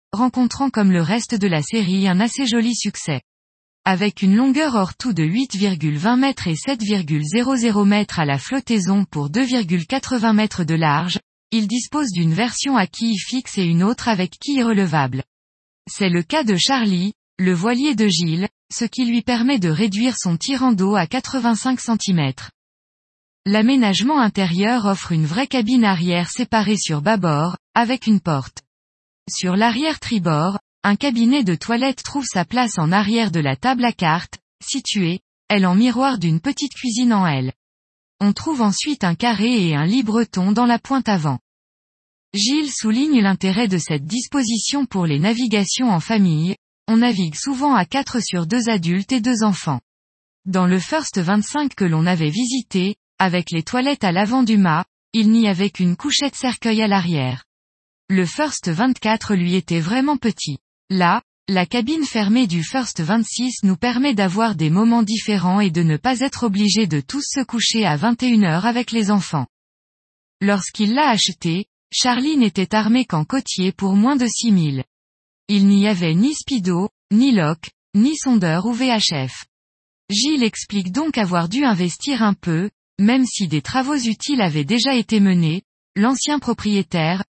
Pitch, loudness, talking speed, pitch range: 210 Hz, -18 LUFS, 160 wpm, 175-245 Hz